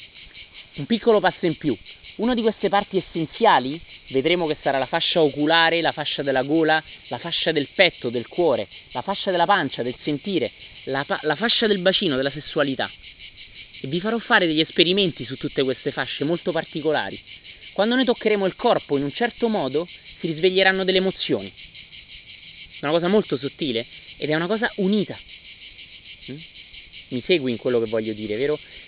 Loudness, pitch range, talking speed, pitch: -22 LUFS, 130-190 Hz, 175 wpm, 155 Hz